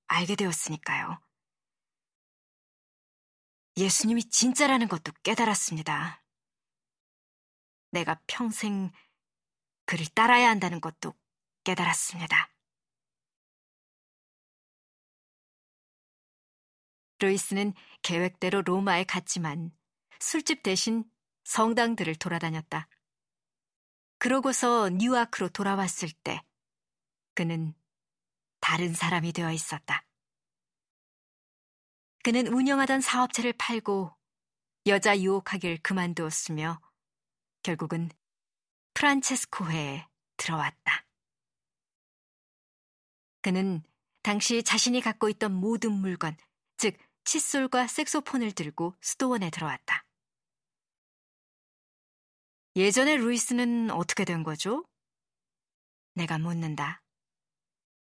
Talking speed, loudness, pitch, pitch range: 190 characters per minute, -28 LUFS, 195 Hz, 165-235 Hz